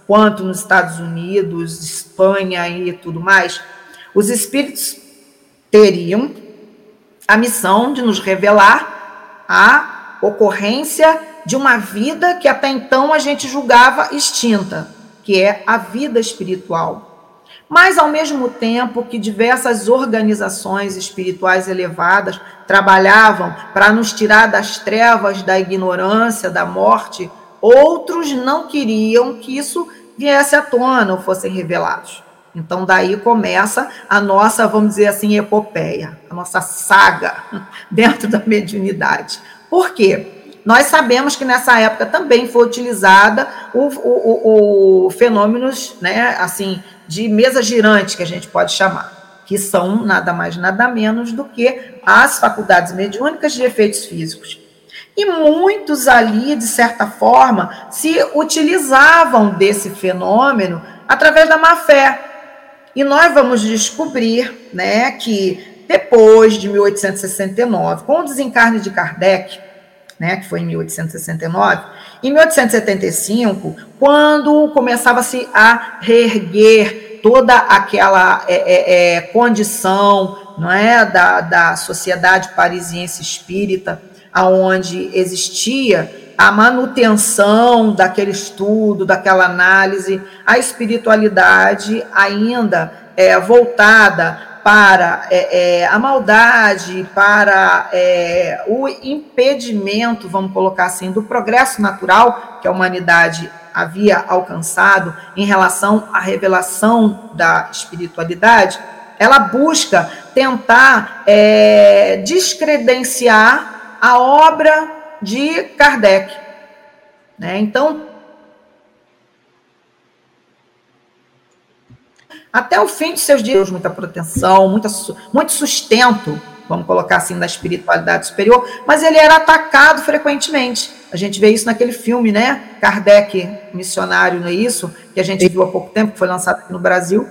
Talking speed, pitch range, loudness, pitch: 115 wpm, 190-260 Hz, -12 LUFS, 215 Hz